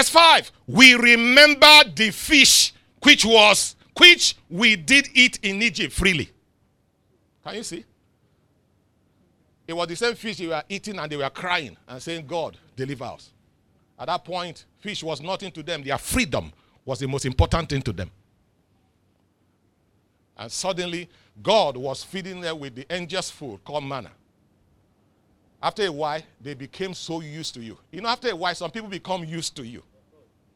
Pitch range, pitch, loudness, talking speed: 120-195 Hz, 165 Hz, -17 LUFS, 165 wpm